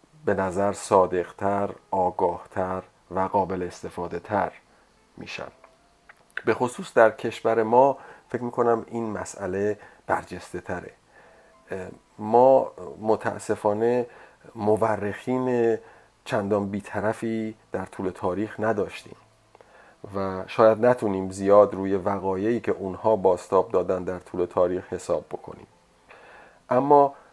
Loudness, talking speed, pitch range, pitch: -24 LUFS, 95 wpm, 95-115 Hz, 105 Hz